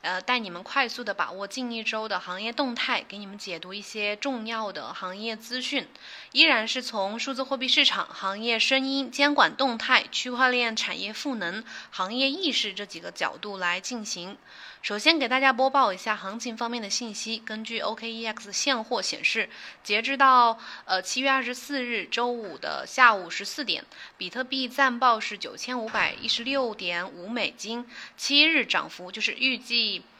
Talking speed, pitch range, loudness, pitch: 270 characters per minute, 205-260 Hz, -25 LUFS, 230 Hz